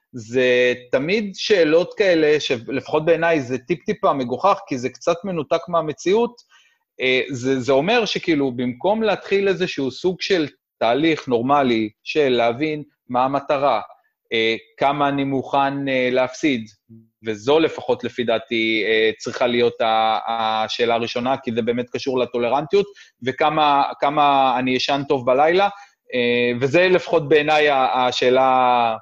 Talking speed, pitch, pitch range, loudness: 115 wpm, 135 Hz, 125-165 Hz, -19 LUFS